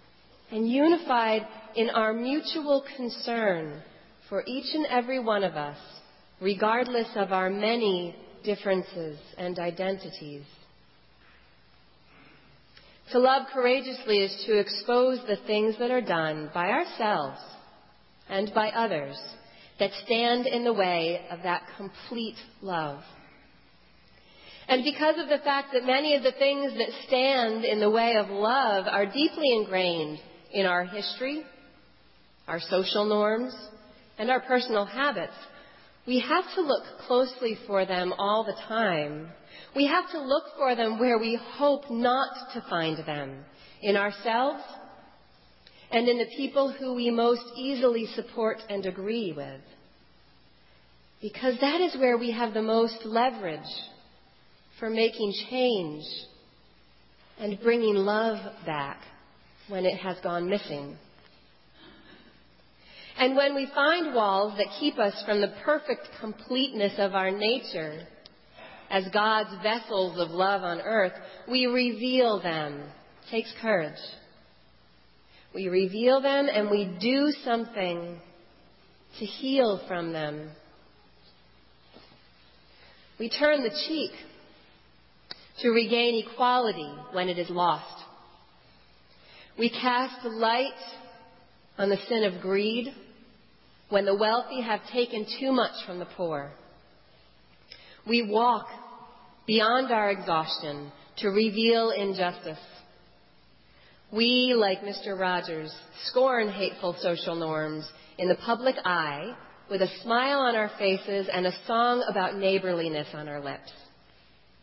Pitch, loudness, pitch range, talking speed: 215 Hz, -27 LUFS, 180-245 Hz, 125 wpm